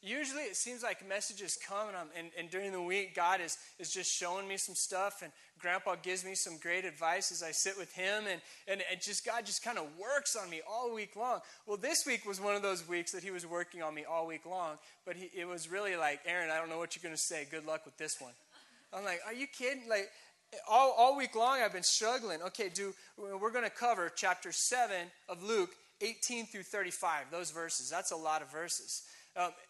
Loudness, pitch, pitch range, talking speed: -36 LUFS, 185 Hz, 170-210 Hz, 240 wpm